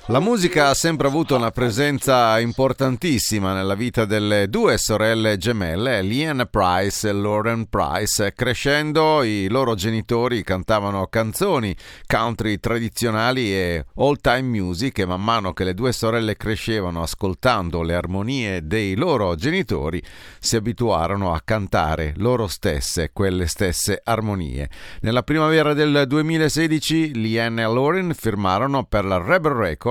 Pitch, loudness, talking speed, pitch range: 115 Hz, -20 LUFS, 130 wpm, 100-130 Hz